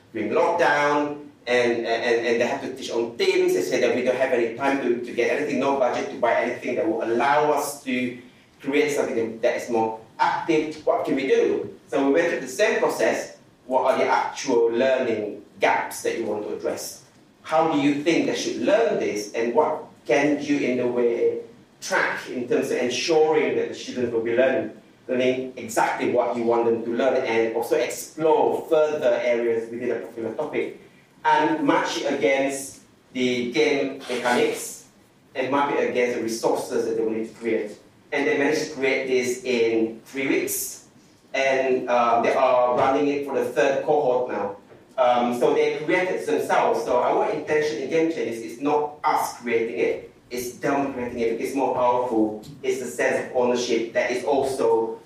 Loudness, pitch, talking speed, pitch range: -23 LUFS, 130 Hz, 190 wpm, 120-150 Hz